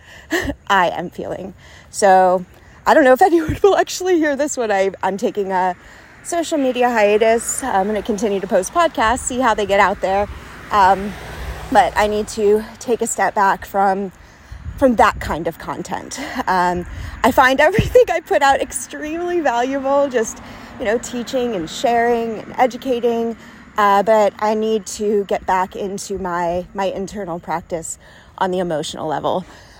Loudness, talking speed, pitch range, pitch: -17 LUFS, 165 wpm, 195-255 Hz, 220 Hz